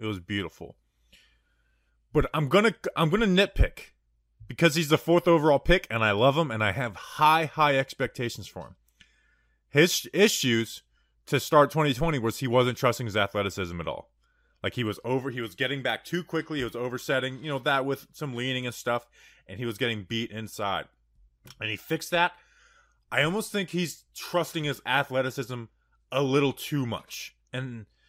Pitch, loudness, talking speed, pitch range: 130 Hz, -27 LUFS, 180 wpm, 115-155 Hz